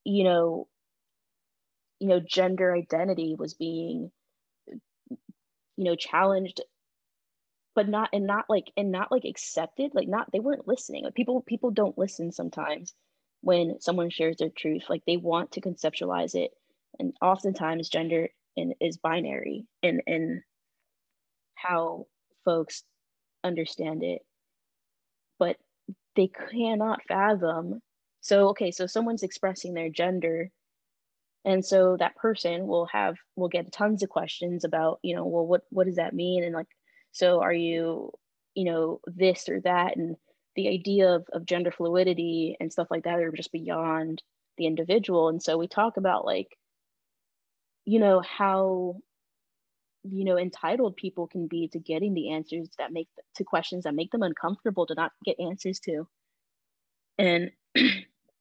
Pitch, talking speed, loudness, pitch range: 180 Hz, 150 wpm, -28 LUFS, 165-200 Hz